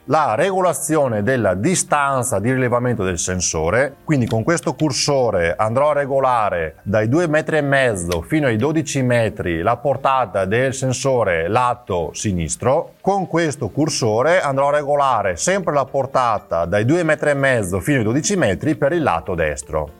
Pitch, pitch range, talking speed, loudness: 135 Hz, 110-155 Hz, 145 wpm, -18 LUFS